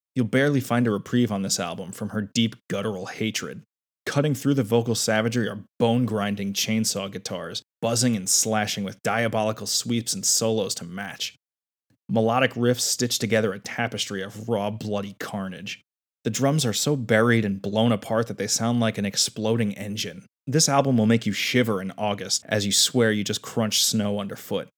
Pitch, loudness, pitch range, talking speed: 110 Hz, -24 LUFS, 100-120 Hz, 180 wpm